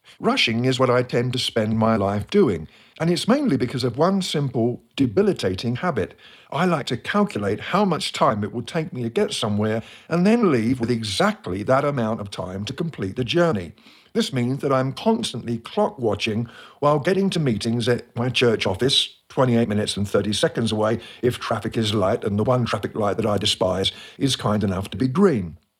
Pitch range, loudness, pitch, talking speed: 110-145 Hz, -22 LUFS, 120 Hz, 200 wpm